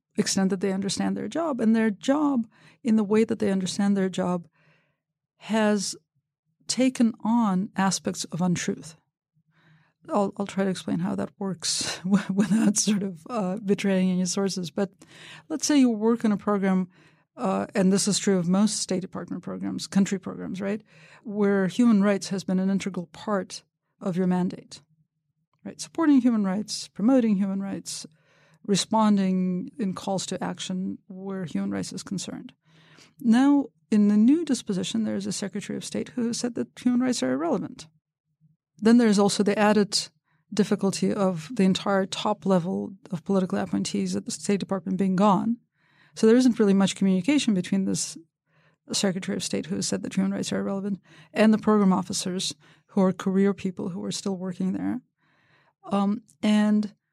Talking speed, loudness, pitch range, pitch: 170 wpm, -25 LUFS, 180-210 Hz, 195 Hz